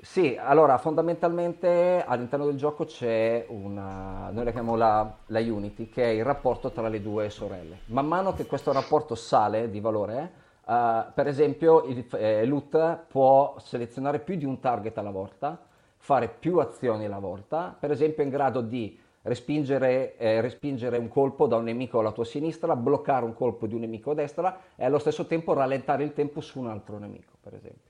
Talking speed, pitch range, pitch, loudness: 185 wpm, 115-150 Hz, 130 Hz, -26 LUFS